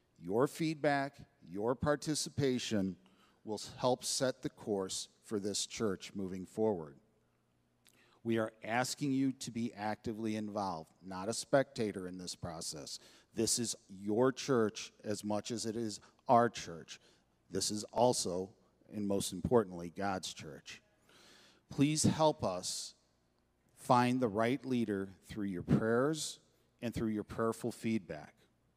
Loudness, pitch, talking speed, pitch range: -36 LUFS, 110 Hz, 130 wpm, 95-125 Hz